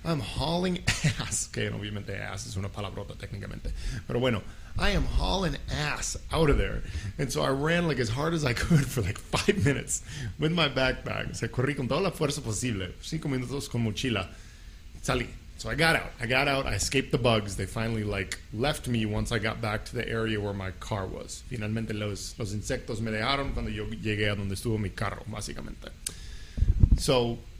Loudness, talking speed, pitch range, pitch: -29 LUFS, 175 wpm, 100-130 Hz, 110 Hz